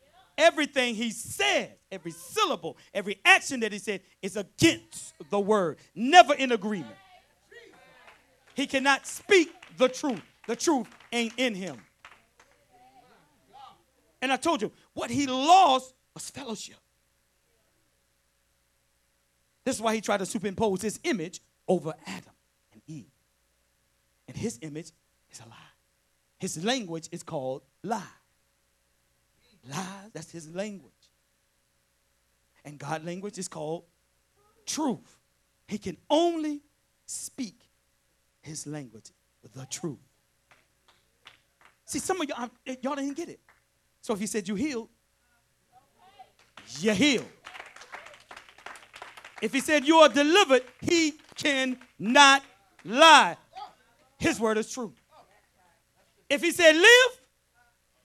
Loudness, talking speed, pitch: -25 LUFS, 115 wpm, 210 Hz